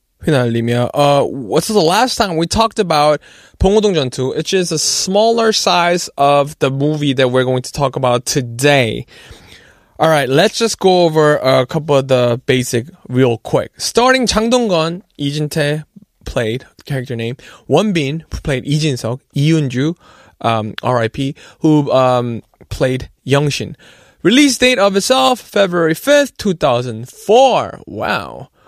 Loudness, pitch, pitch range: -14 LUFS, 150 Hz, 130-190 Hz